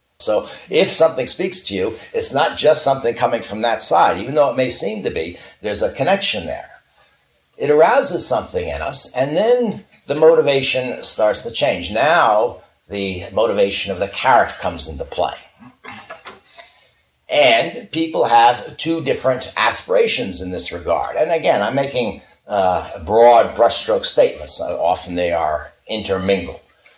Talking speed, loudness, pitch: 150 wpm, -17 LUFS, 155 Hz